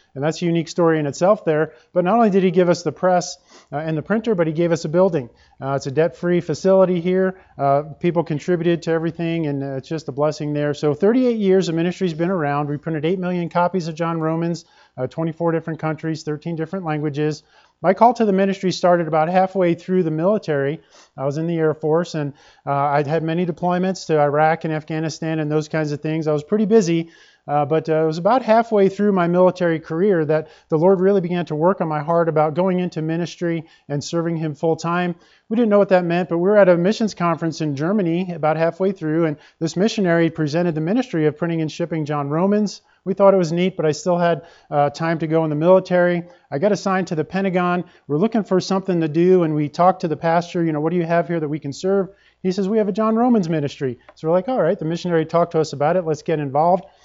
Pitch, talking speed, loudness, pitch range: 170 Hz, 240 wpm, -19 LUFS, 155-185 Hz